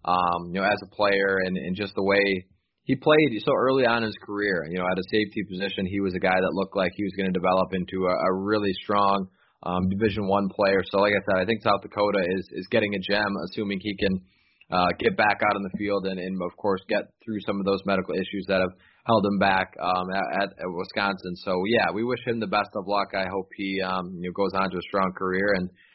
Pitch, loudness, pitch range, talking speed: 100 Hz, -25 LUFS, 95-105 Hz, 255 wpm